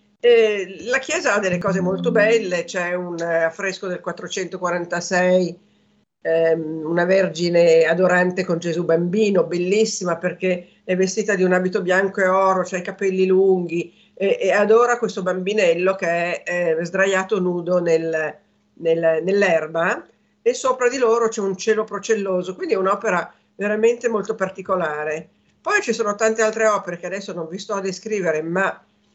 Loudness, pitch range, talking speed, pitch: -20 LUFS, 175-205 Hz, 160 wpm, 185 Hz